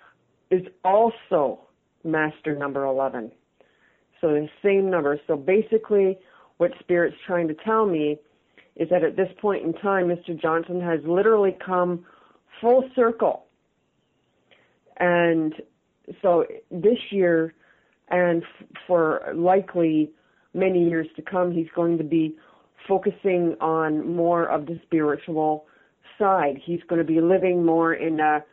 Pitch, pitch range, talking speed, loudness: 170 Hz, 160-190 Hz, 130 wpm, -23 LUFS